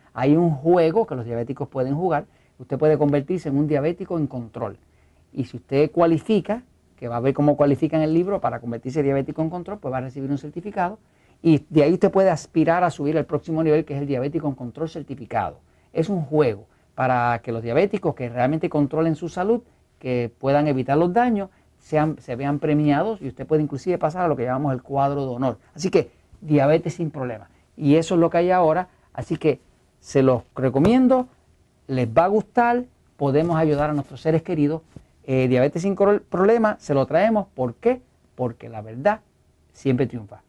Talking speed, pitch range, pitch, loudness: 200 wpm, 130-170 Hz, 150 Hz, -22 LUFS